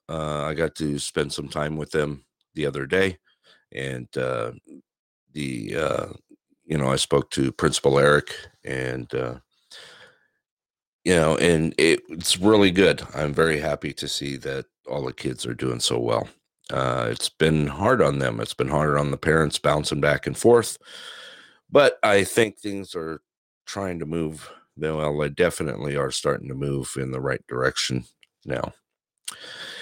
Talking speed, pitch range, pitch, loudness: 165 wpm, 70-80 Hz, 75 Hz, -23 LUFS